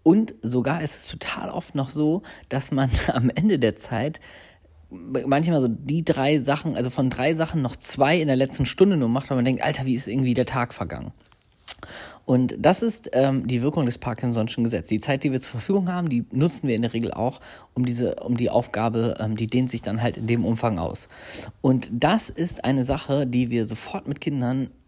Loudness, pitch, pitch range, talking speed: -24 LUFS, 130 Hz, 120-145 Hz, 215 wpm